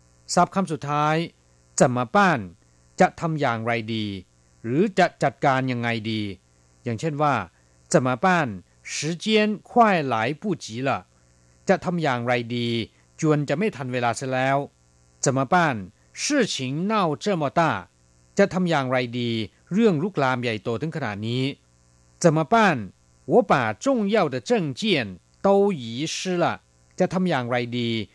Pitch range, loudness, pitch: 105-170 Hz, -23 LUFS, 130 Hz